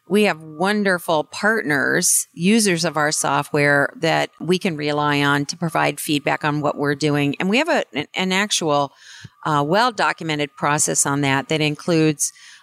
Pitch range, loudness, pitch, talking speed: 145-180 Hz, -19 LUFS, 155 Hz, 160 wpm